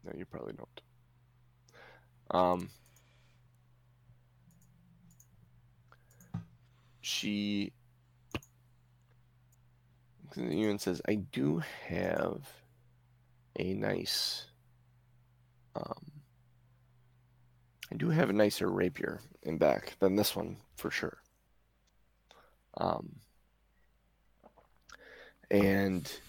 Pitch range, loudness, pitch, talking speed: 115-125 Hz, -34 LUFS, 125 Hz, 65 wpm